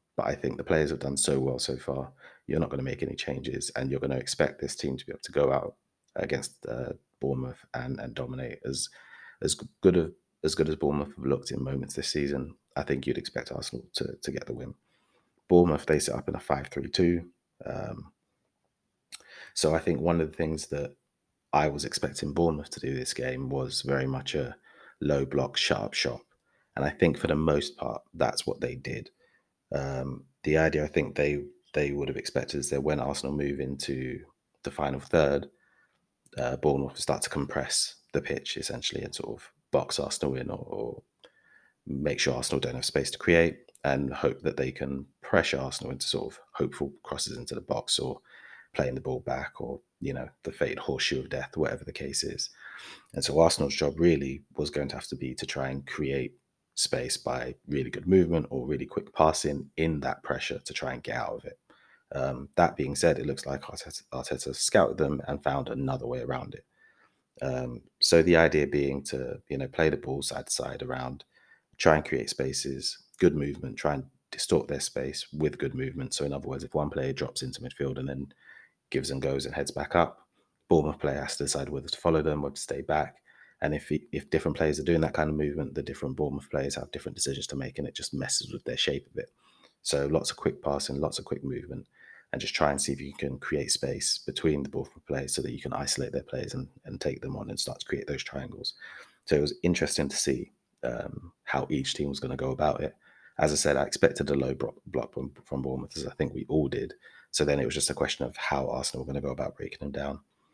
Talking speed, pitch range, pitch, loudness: 225 wpm, 70-75 Hz, 70 Hz, -30 LUFS